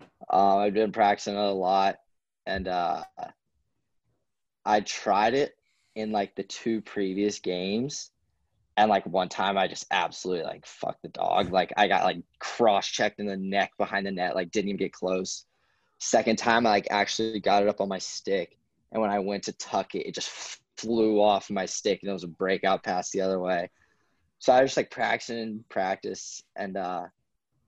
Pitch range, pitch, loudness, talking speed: 95-110 Hz, 100 Hz, -27 LUFS, 195 wpm